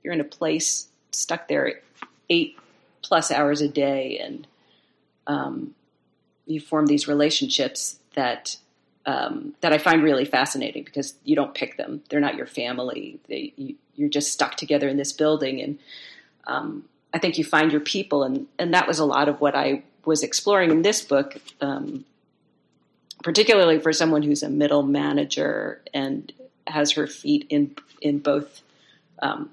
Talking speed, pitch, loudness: 165 wpm, 155 Hz, -23 LUFS